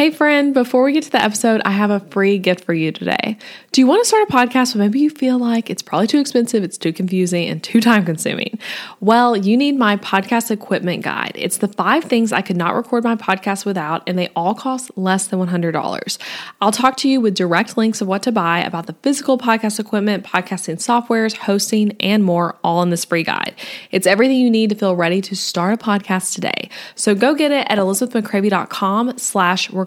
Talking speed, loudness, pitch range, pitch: 220 wpm, -17 LUFS, 190-245 Hz, 210 Hz